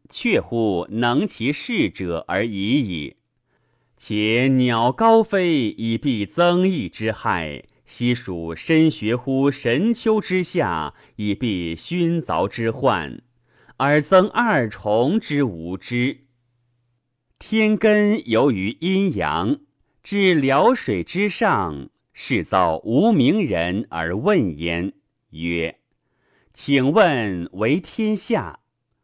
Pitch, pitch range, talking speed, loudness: 130 Hz, 110-185 Hz, 135 characters per minute, -20 LUFS